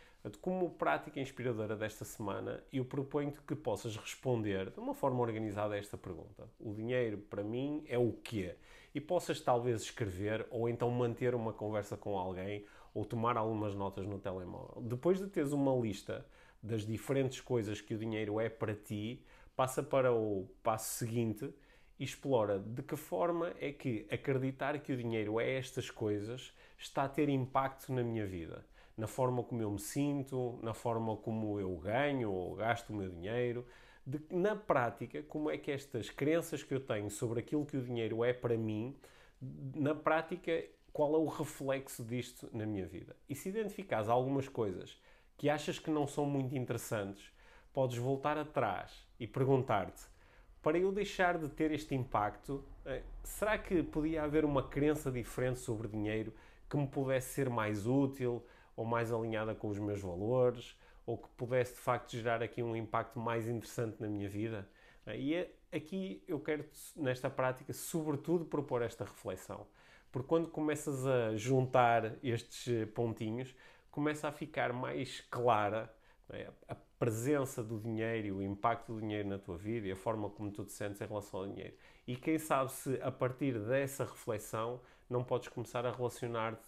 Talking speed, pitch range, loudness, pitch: 170 wpm, 110-140 Hz, -37 LUFS, 125 Hz